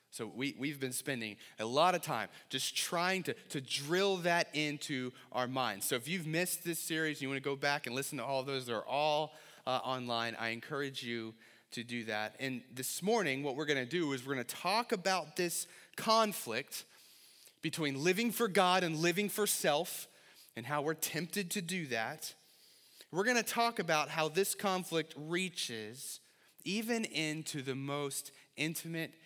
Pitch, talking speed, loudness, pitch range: 150 Hz, 190 wpm, -35 LUFS, 130-180 Hz